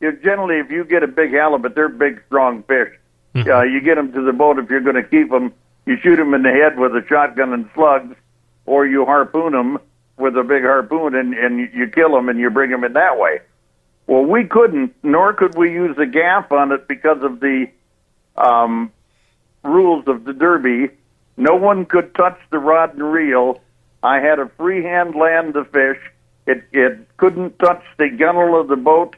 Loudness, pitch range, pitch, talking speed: -15 LUFS, 130-165 Hz, 145 Hz, 205 wpm